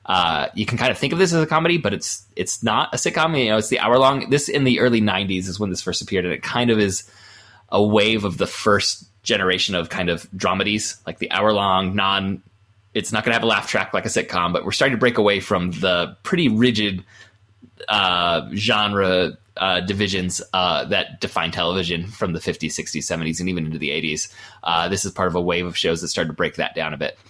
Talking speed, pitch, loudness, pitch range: 240 wpm, 100 Hz, -20 LUFS, 95-110 Hz